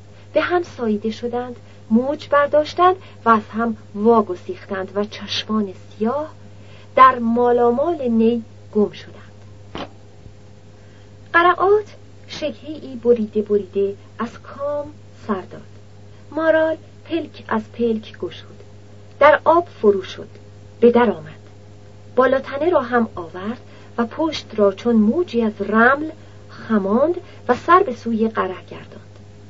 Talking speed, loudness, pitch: 115 wpm, -19 LUFS, 215 Hz